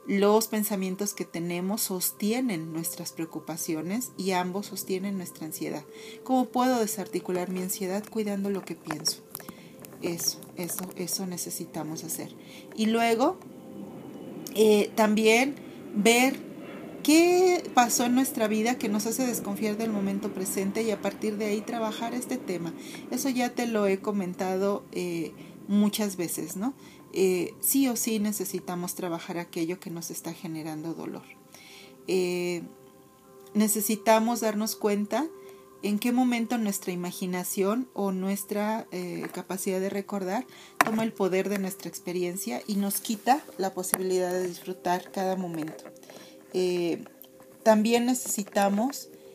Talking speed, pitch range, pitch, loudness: 130 wpm, 180-225 Hz, 200 Hz, -28 LUFS